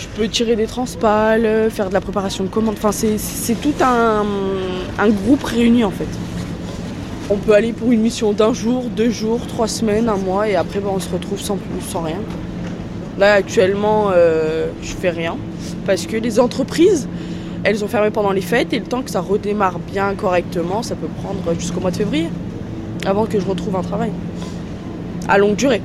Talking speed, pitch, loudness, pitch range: 195 wpm, 205 Hz, -18 LUFS, 185-225 Hz